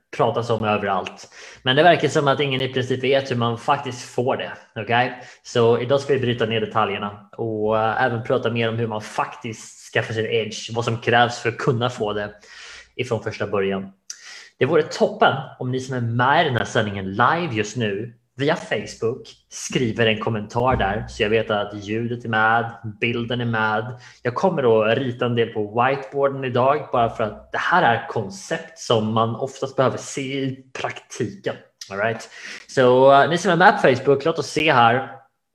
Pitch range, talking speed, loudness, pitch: 110-135 Hz, 195 wpm, -21 LUFS, 120 Hz